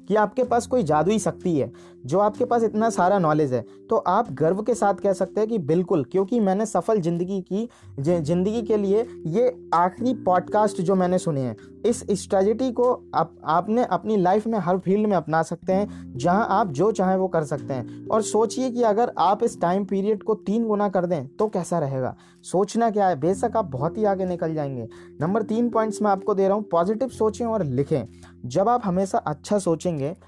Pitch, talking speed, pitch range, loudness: 190 Hz, 205 wpm, 165-220 Hz, -23 LUFS